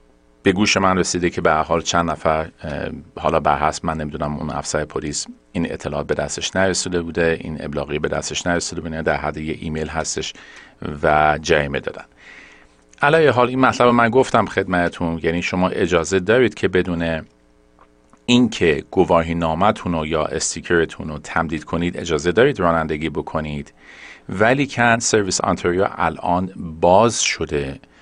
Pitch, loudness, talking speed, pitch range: 85 Hz, -19 LUFS, 150 wpm, 75-95 Hz